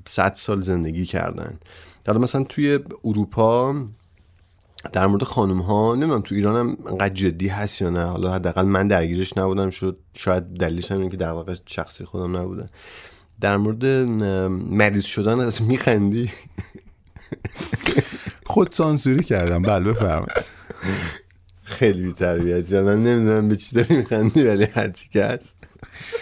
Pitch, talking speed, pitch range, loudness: 100 Hz, 140 wpm, 90-110 Hz, -21 LUFS